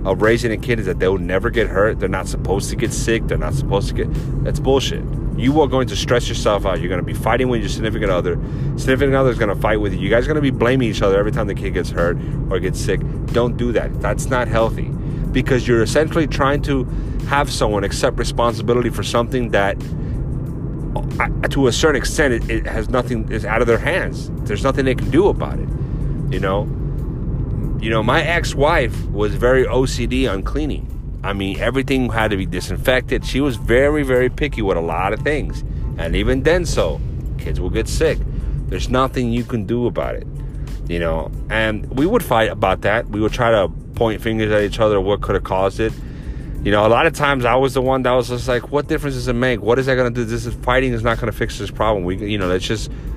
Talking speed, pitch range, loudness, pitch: 235 wpm, 115-135 Hz, -19 LUFS, 125 Hz